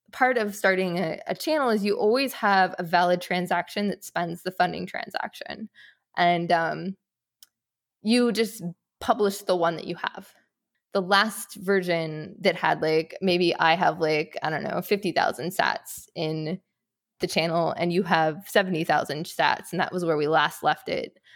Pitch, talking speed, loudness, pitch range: 185 Hz, 165 wpm, -25 LUFS, 170-205 Hz